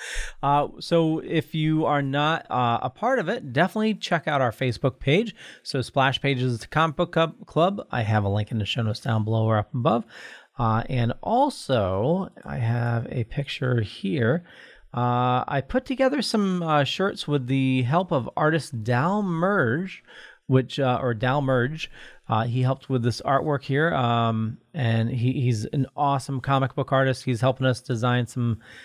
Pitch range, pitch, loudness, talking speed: 120-160 Hz, 135 Hz, -24 LUFS, 175 wpm